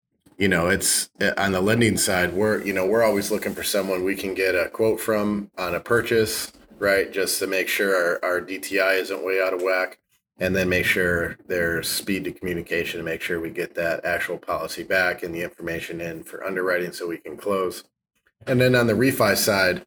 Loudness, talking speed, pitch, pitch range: -23 LUFS, 210 wpm, 100 Hz, 95-110 Hz